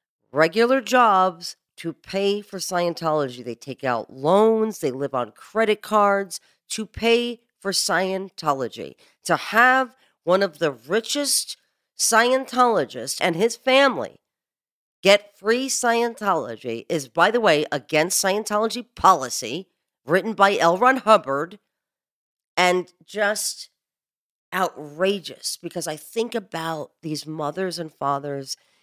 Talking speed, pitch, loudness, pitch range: 115 wpm, 190 Hz, -21 LUFS, 155-225 Hz